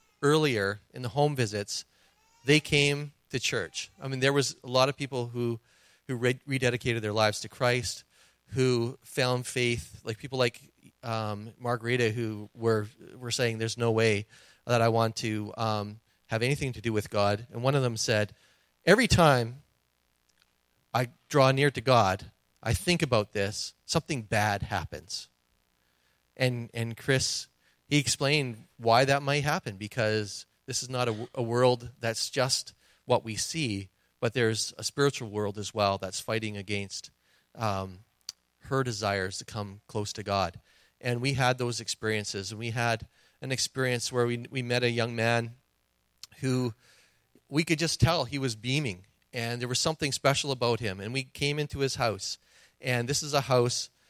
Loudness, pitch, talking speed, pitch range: -29 LUFS, 120 Hz, 170 wpm, 105-130 Hz